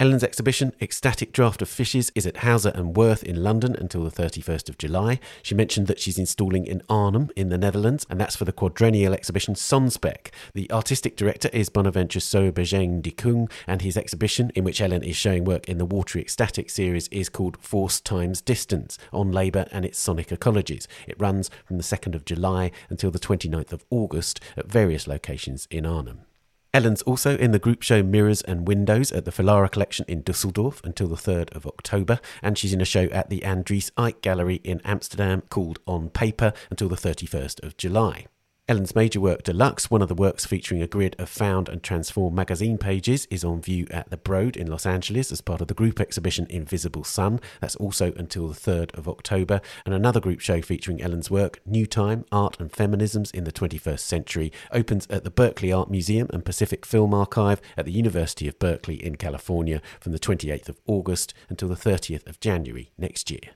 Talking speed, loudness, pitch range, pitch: 200 wpm, -24 LUFS, 90-105 Hz, 95 Hz